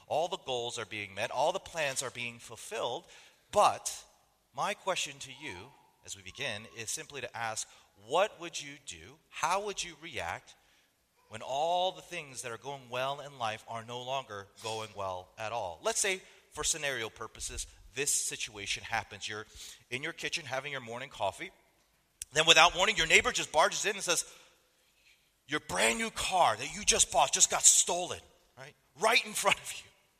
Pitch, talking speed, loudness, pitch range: 135 Hz, 185 wpm, -31 LUFS, 110-170 Hz